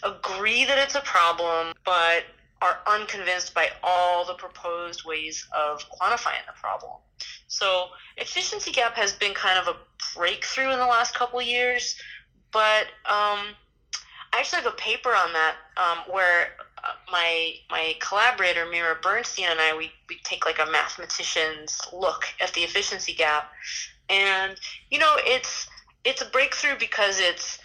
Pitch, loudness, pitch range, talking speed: 185 Hz, -24 LUFS, 170-245 Hz, 150 wpm